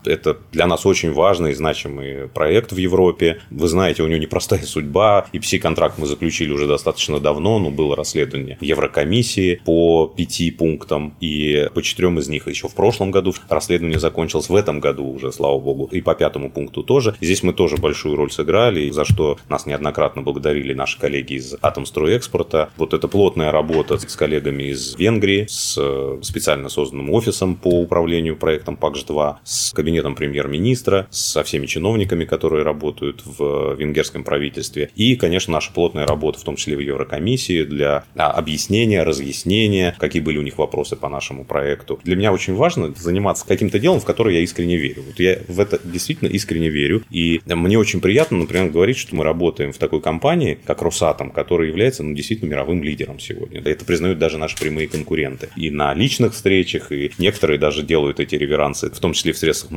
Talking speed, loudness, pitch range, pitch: 180 wpm, -19 LUFS, 75-95 Hz, 80 Hz